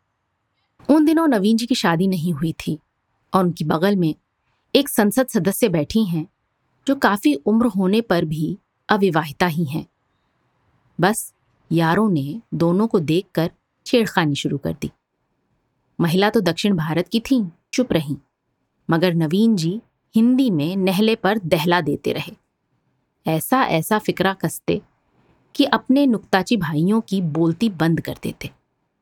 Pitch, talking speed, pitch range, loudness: 185 Hz, 145 wpm, 160-225 Hz, -20 LUFS